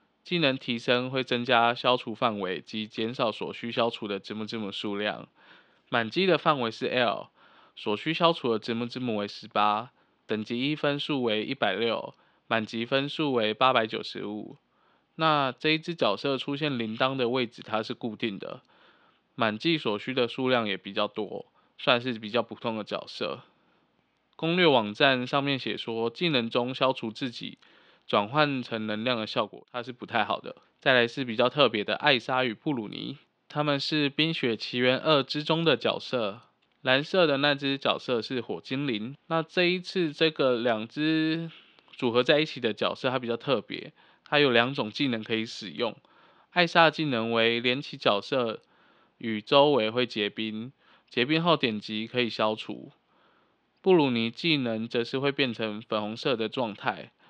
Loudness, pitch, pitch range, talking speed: -27 LUFS, 125 Hz, 115-145 Hz, 250 characters per minute